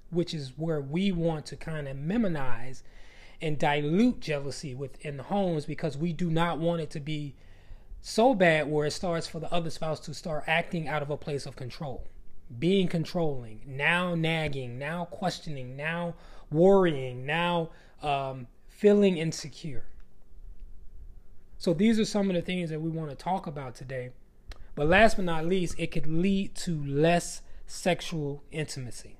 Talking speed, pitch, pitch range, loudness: 160 wpm, 160 Hz, 140-175 Hz, -29 LUFS